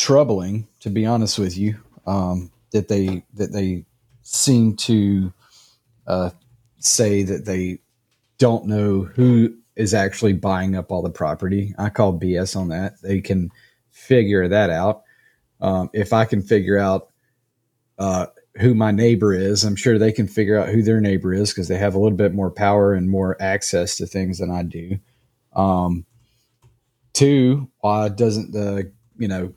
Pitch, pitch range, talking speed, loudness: 105 Hz, 95-115 Hz, 165 wpm, -20 LUFS